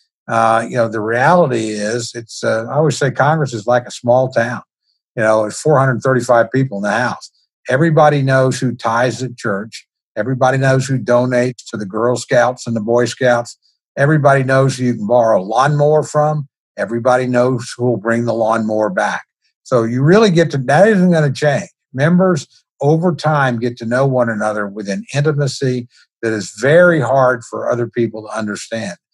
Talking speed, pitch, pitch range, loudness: 185 wpm, 125 Hz, 115-140 Hz, -15 LUFS